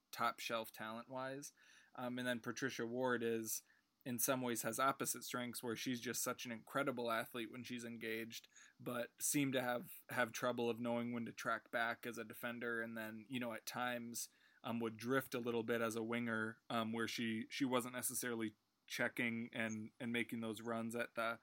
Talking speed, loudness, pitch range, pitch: 195 wpm, -43 LUFS, 115-125 Hz, 120 Hz